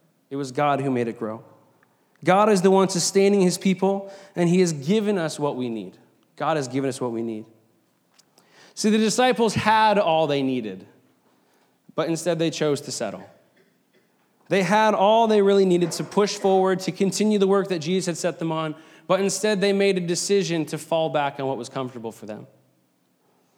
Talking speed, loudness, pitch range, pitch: 195 wpm, -22 LUFS, 135-195 Hz, 170 Hz